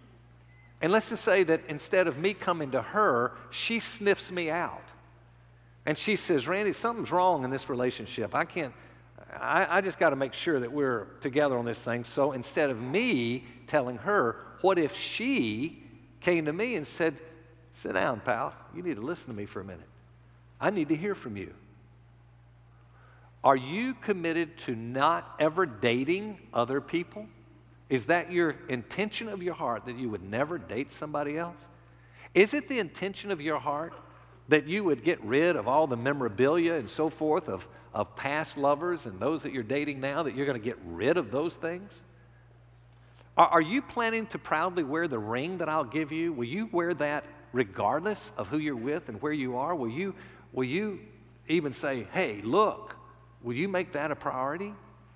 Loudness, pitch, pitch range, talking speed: -30 LUFS, 145 Hz, 120-170 Hz, 185 wpm